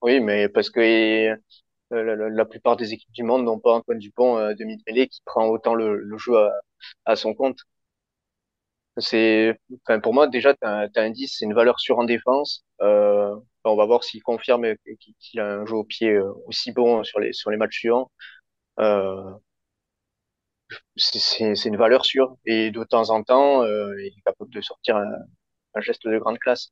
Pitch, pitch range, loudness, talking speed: 110 Hz, 105-120 Hz, -21 LUFS, 190 wpm